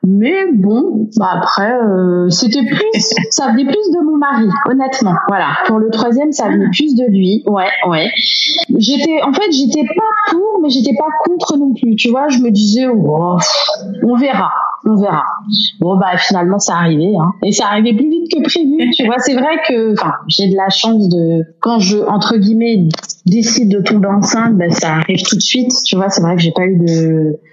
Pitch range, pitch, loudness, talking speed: 190-265 Hz, 220 Hz, -12 LUFS, 205 wpm